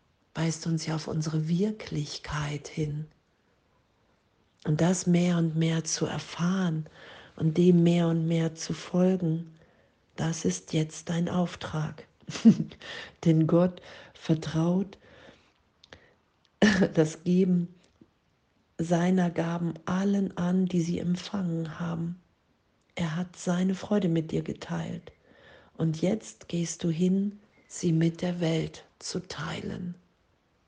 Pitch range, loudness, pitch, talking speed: 160-180 Hz, -28 LUFS, 170 Hz, 110 wpm